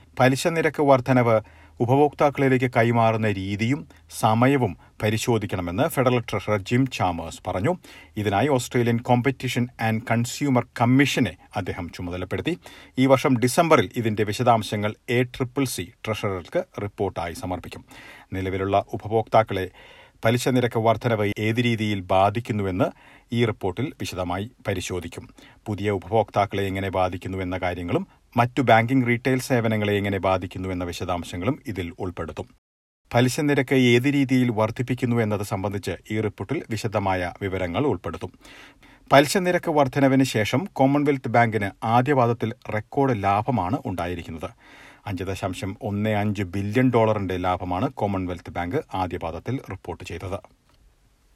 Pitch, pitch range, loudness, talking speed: 110 Hz, 95-125 Hz, -23 LUFS, 110 wpm